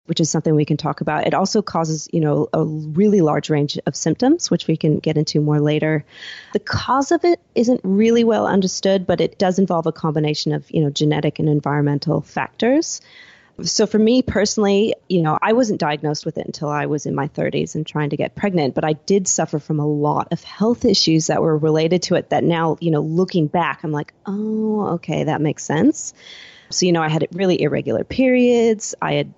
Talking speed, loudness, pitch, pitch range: 215 wpm, -19 LUFS, 165 Hz, 150-200 Hz